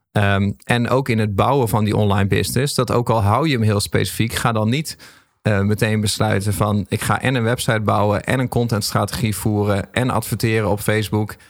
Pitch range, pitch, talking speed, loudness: 105-120 Hz, 110 Hz, 205 wpm, -19 LUFS